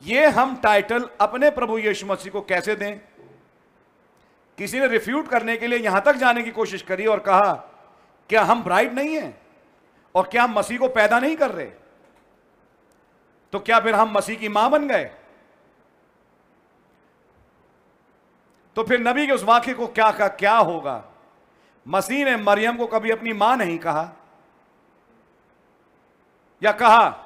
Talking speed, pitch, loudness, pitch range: 150 wpm, 225 Hz, -20 LUFS, 205-250 Hz